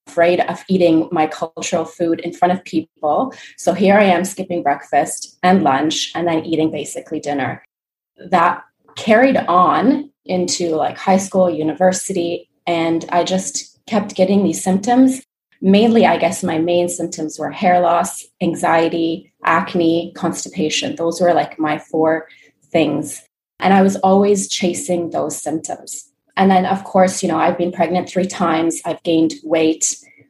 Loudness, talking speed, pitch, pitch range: -17 LUFS, 155 wpm, 175 Hz, 165-185 Hz